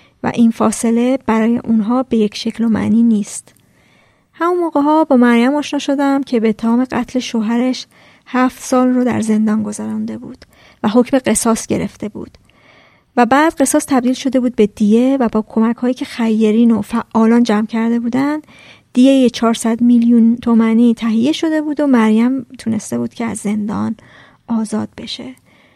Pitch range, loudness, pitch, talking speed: 225-255 Hz, -14 LUFS, 235 Hz, 165 wpm